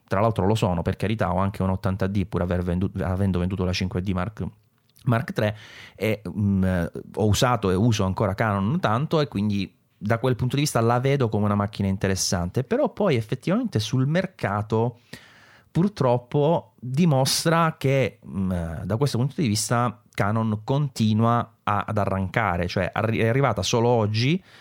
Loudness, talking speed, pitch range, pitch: -24 LUFS, 165 wpm, 95-125 Hz, 110 Hz